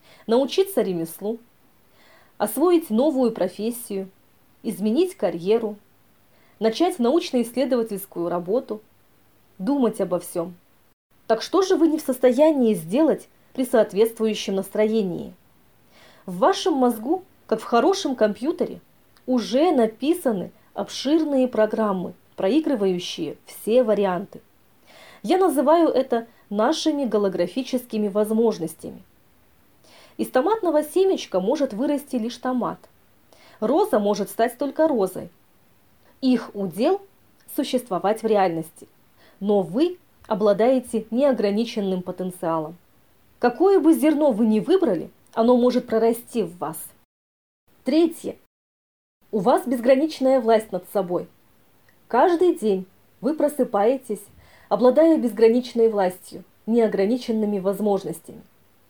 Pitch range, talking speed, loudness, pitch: 200-275 Hz, 95 wpm, -22 LUFS, 230 Hz